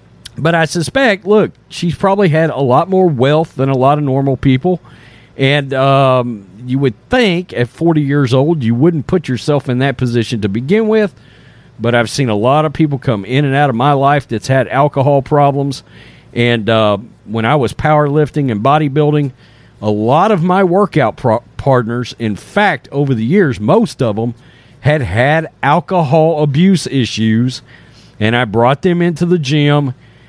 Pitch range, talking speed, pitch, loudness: 120-160 Hz, 175 wpm, 140 Hz, -13 LUFS